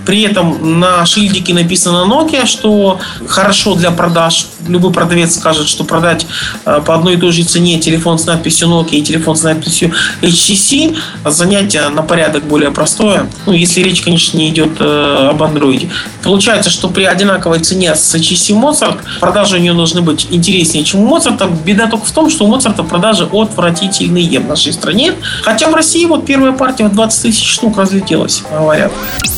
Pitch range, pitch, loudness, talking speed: 165-200 Hz, 175 Hz, -9 LUFS, 170 wpm